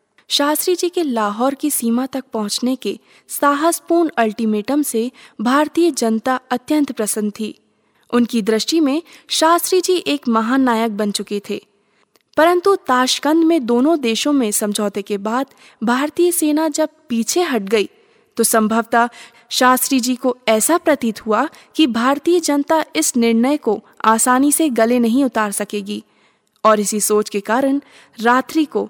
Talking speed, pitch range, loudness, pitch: 145 wpm, 220-300 Hz, -17 LUFS, 250 Hz